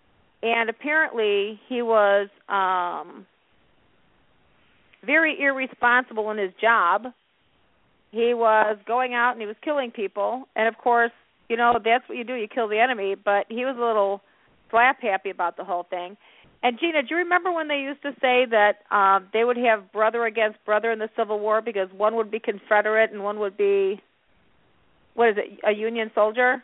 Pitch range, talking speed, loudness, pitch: 210-250 Hz, 180 wpm, -23 LUFS, 225 Hz